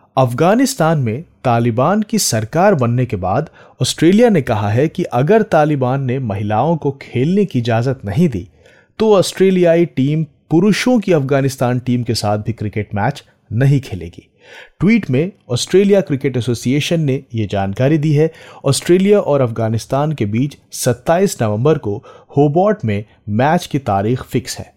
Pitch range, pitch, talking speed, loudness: 115-170 Hz, 135 Hz, 150 wpm, -15 LUFS